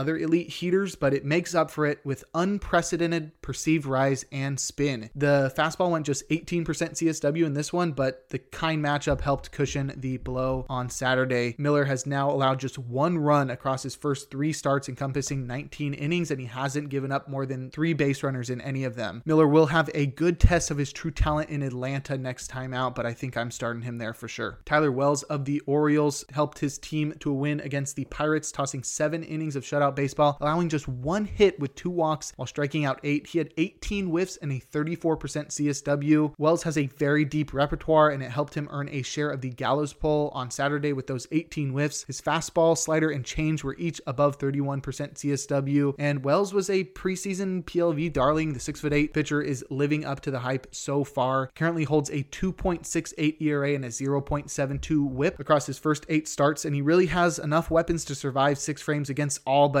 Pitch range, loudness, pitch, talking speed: 135-155 Hz, -27 LUFS, 145 Hz, 205 wpm